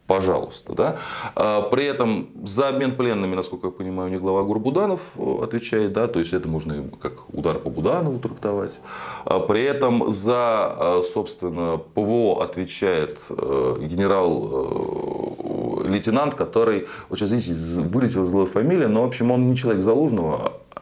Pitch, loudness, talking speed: 115 Hz, -22 LUFS, 135 wpm